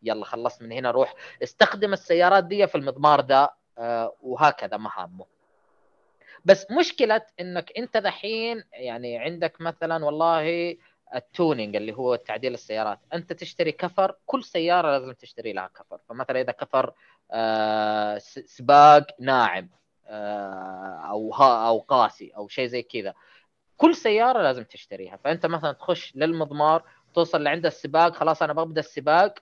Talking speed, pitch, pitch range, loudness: 135 wpm, 155 Hz, 120-180 Hz, -23 LUFS